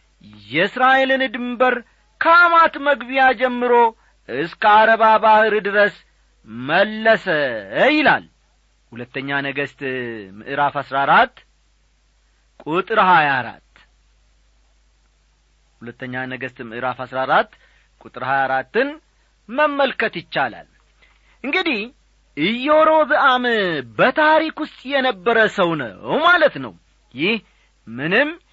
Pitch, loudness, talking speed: 205 Hz, -17 LUFS, 85 wpm